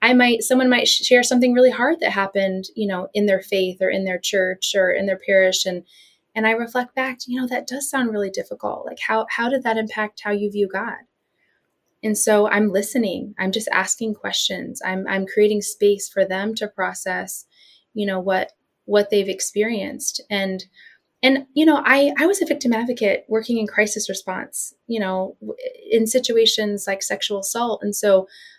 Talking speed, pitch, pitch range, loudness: 190 wpm, 210 Hz, 195-245 Hz, -20 LUFS